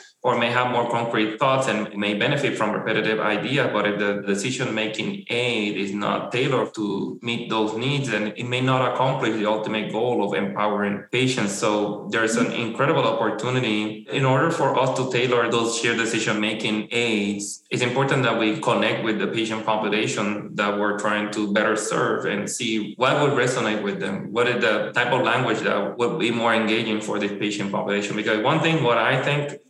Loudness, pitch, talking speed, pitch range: -22 LUFS, 110 Hz, 190 wpm, 105-125 Hz